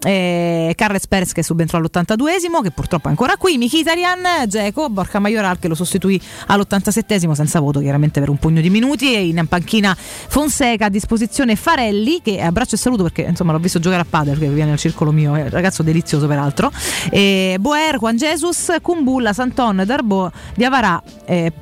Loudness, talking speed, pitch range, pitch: -16 LUFS, 180 wpm, 170-245 Hz, 195 Hz